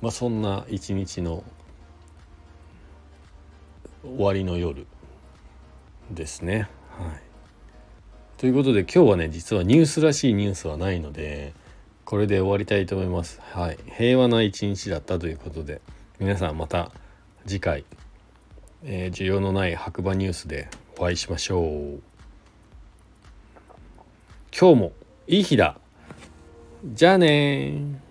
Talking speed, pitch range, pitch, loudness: 250 characters per minute, 80-105 Hz, 90 Hz, -23 LUFS